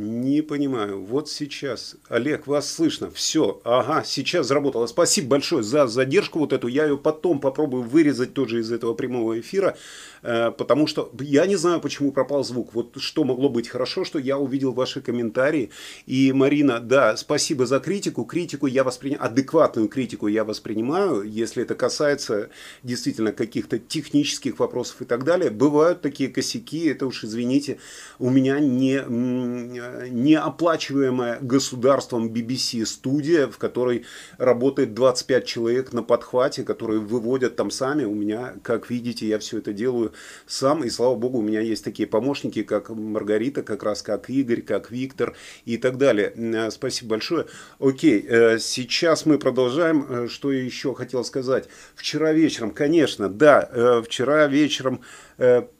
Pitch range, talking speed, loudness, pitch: 120-145 Hz, 145 wpm, -22 LUFS, 130 Hz